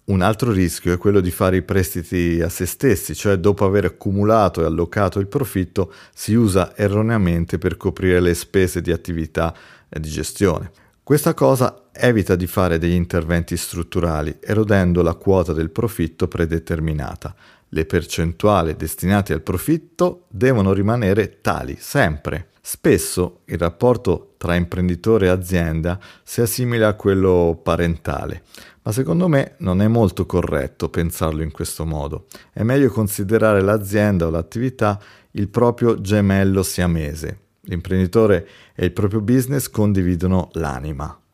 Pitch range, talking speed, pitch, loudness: 85-105 Hz, 140 wpm, 95 Hz, -19 LUFS